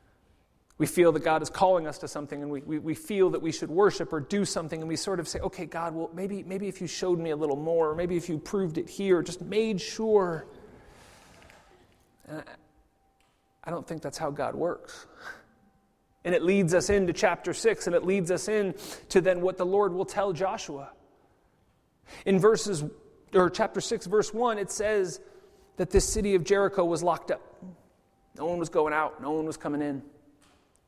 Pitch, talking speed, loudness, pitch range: 180 Hz, 200 wpm, -28 LUFS, 160-195 Hz